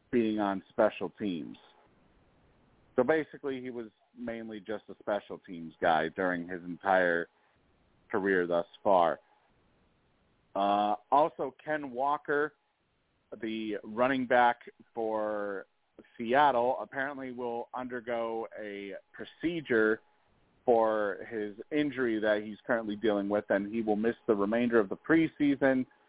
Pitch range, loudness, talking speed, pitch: 105-130 Hz, -31 LUFS, 115 wpm, 115 Hz